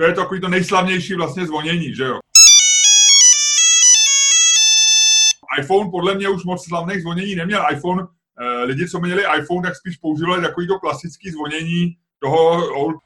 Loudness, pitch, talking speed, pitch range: -12 LUFS, 180 Hz, 145 wpm, 165-200 Hz